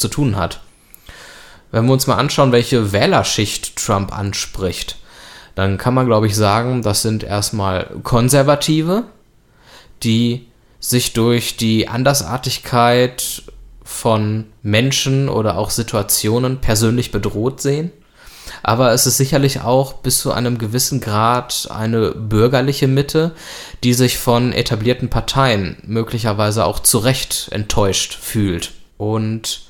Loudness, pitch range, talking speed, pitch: -16 LUFS, 110-130 Hz, 120 wpm, 120 Hz